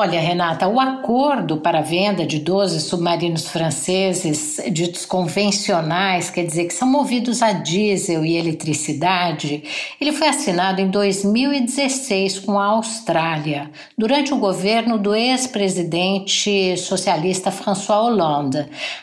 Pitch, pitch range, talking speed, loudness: 190 Hz, 170-210 Hz, 120 wpm, -19 LUFS